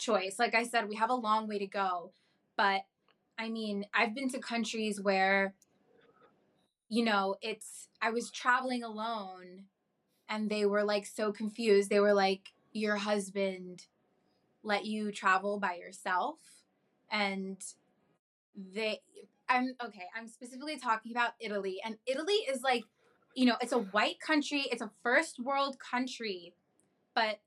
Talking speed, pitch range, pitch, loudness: 145 wpm, 200-240 Hz, 215 Hz, -33 LUFS